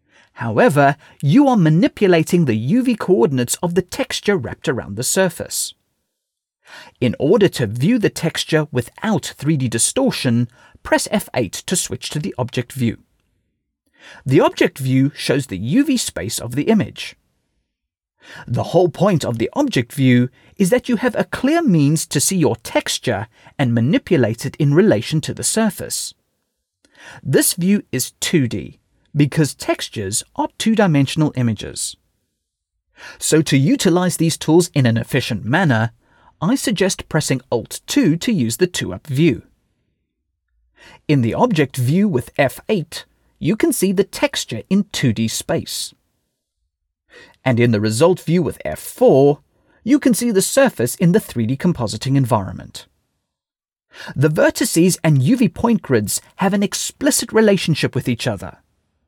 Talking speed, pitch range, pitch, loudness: 140 wpm, 120-195 Hz, 150 Hz, -17 LUFS